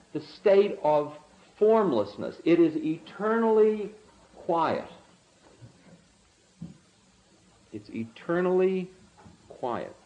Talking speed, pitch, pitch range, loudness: 65 wpm, 200 Hz, 175-220 Hz, -26 LUFS